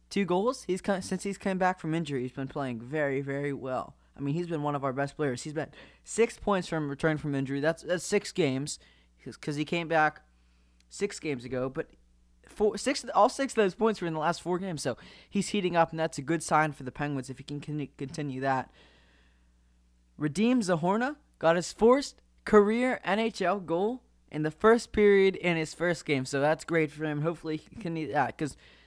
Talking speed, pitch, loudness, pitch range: 210 wpm, 155 Hz, -29 LUFS, 140-190 Hz